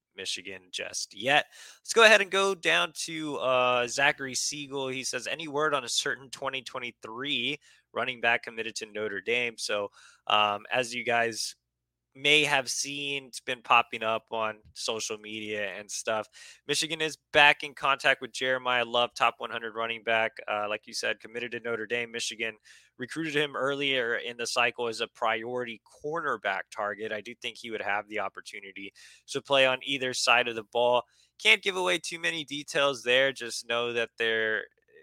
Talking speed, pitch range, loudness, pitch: 175 wpm, 115-140 Hz, -28 LUFS, 120 Hz